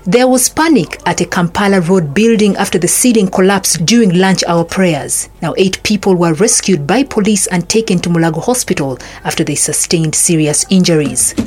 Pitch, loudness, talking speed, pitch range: 185 Hz, -11 LUFS, 175 wpm, 170-215 Hz